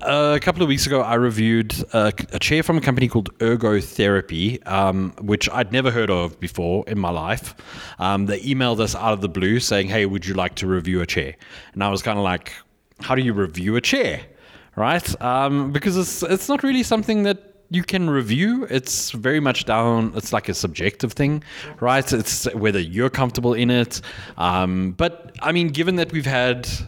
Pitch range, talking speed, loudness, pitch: 100-140 Hz, 205 wpm, -21 LUFS, 120 Hz